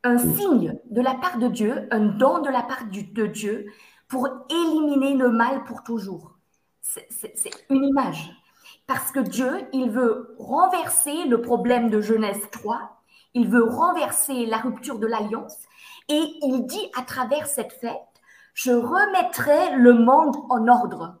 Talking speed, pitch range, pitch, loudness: 160 wpm, 230-275 Hz, 250 Hz, -22 LUFS